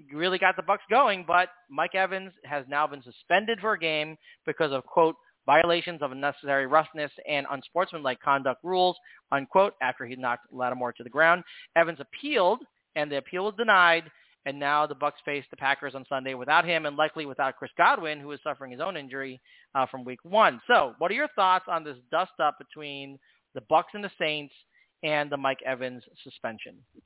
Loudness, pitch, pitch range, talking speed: -27 LUFS, 150 Hz, 140-175 Hz, 195 wpm